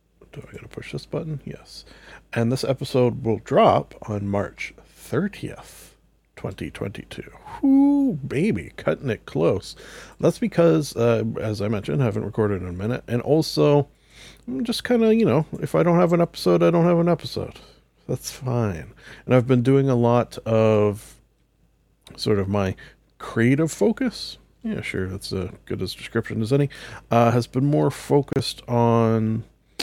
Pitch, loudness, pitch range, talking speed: 125 Hz, -22 LUFS, 110-155 Hz, 165 wpm